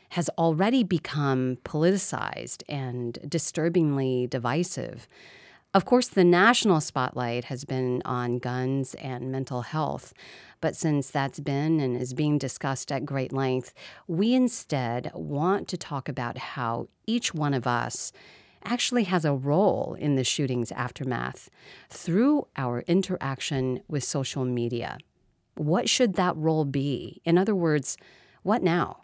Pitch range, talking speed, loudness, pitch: 130-175 Hz, 135 wpm, -27 LUFS, 145 Hz